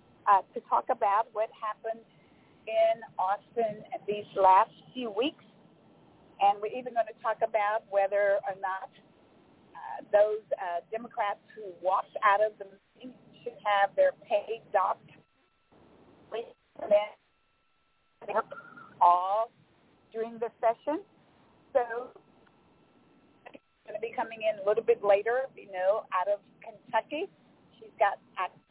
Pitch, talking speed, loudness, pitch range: 220 Hz, 120 wpm, -29 LUFS, 200-255 Hz